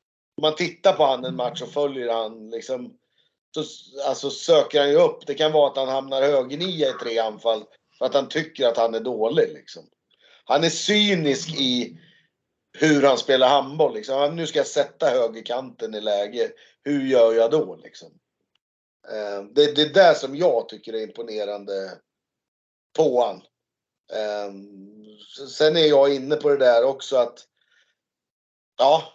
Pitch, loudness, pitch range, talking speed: 140 Hz, -21 LUFS, 115-155 Hz, 165 wpm